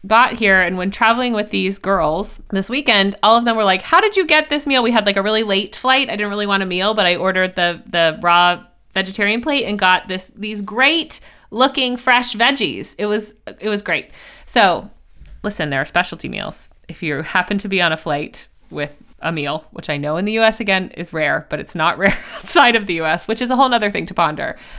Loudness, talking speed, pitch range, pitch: -16 LUFS, 235 wpm, 175-230 Hz, 205 Hz